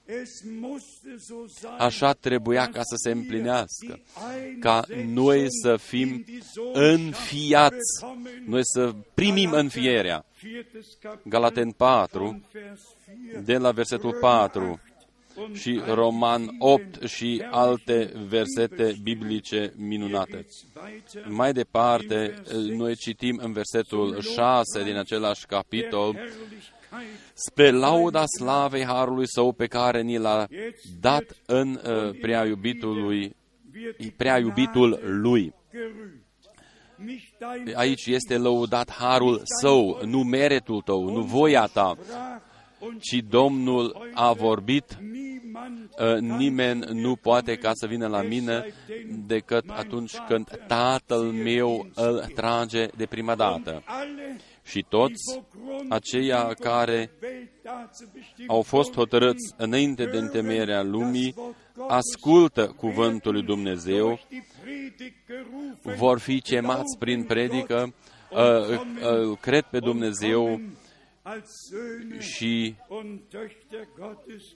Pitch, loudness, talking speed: 125 Hz, -24 LUFS, 95 wpm